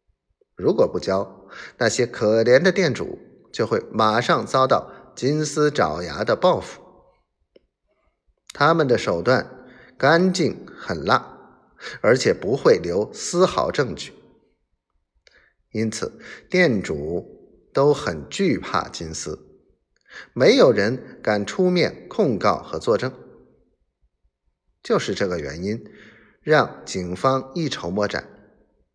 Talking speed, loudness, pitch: 160 characters per minute, -21 LUFS, 130 Hz